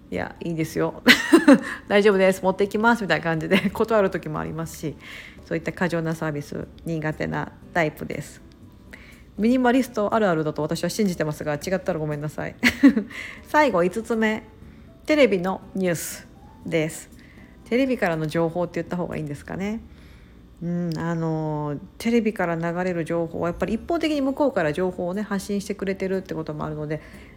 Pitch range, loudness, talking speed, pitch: 160-215 Hz, -23 LUFS, 375 characters per minute, 185 Hz